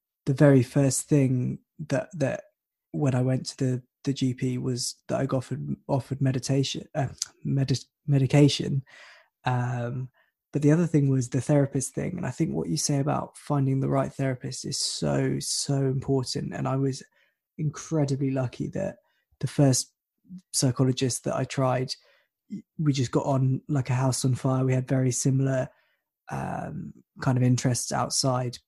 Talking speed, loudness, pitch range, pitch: 160 wpm, -26 LUFS, 130-145 Hz, 135 Hz